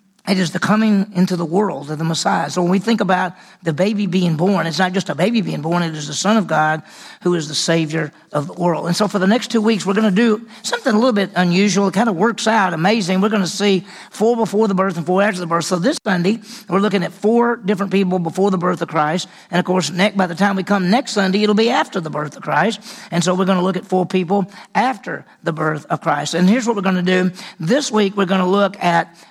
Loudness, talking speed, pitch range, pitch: -17 LUFS, 270 wpm, 175-210 Hz, 190 Hz